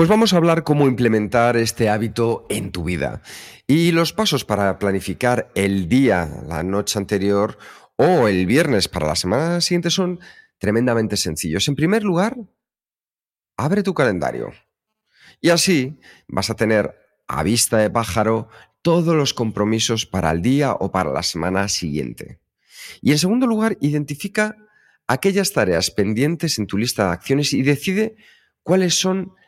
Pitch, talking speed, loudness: 120 Hz, 150 wpm, -19 LUFS